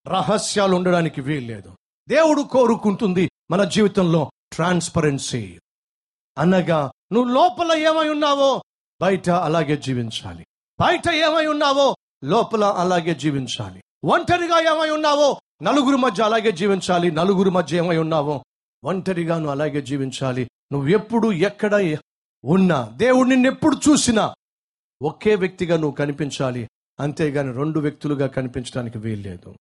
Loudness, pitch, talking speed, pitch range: -20 LUFS, 175 Hz, 105 wpm, 145-225 Hz